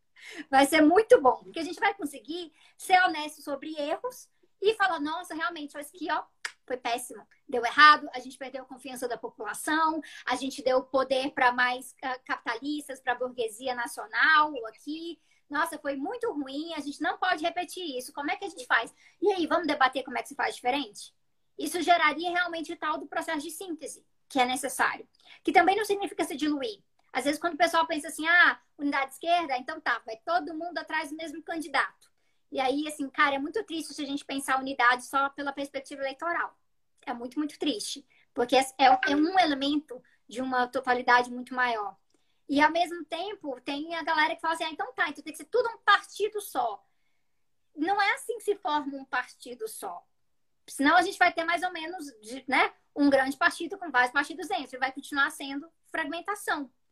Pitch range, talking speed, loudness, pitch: 265-345 Hz, 200 wpm, -28 LUFS, 300 Hz